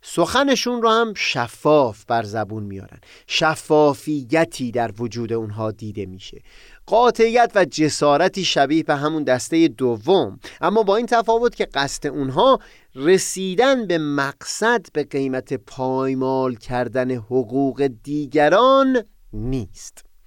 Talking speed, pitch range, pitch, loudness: 115 wpm, 125-190 Hz, 145 Hz, -19 LUFS